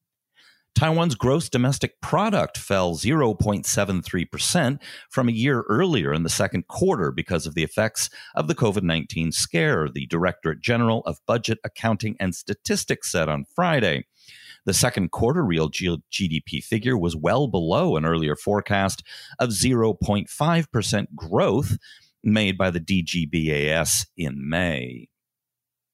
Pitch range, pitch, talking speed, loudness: 80-120 Hz, 100 Hz, 125 wpm, -23 LUFS